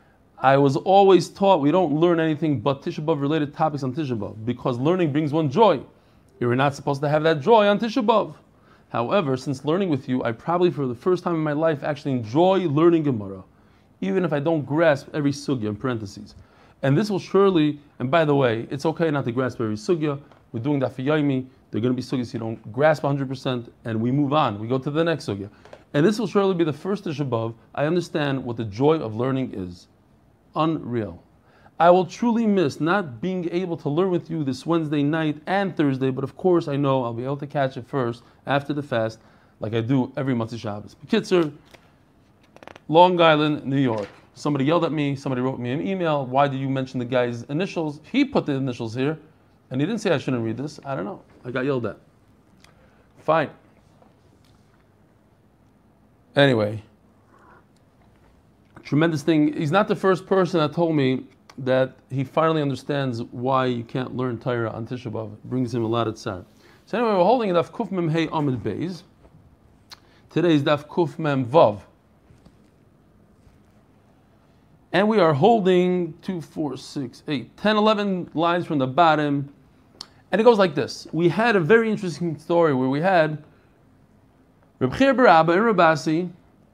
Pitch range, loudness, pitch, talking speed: 125-170 Hz, -22 LUFS, 145 Hz, 190 wpm